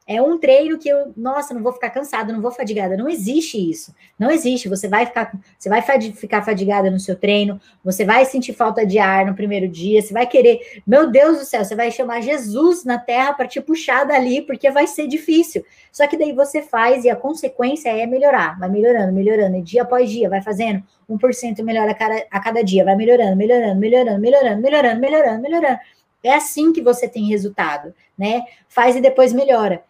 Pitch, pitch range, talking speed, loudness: 240 Hz, 210-270 Hz, 205 wpm, -17 LUFS